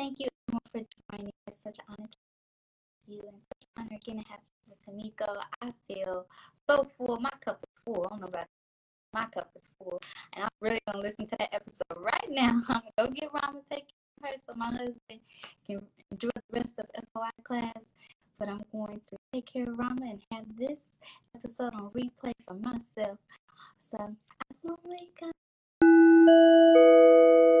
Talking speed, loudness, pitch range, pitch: 190 wpm, -26 LUFS, 205-255 Hz, 225 Hz